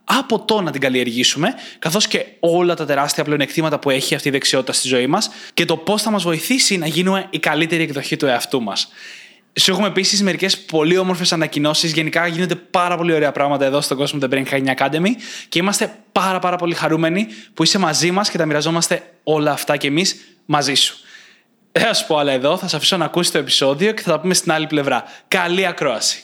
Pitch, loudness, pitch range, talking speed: 165 Hz, -17 LUFS, 150-190 Hz, 215 wpm